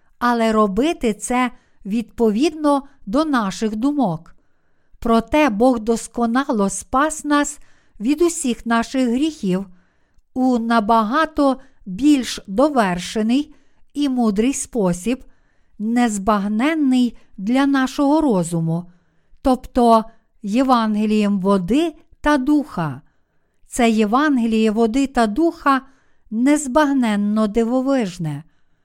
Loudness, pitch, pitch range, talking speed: -19 LUFS, 240 Hz, 215-275 Hz, 80 wpm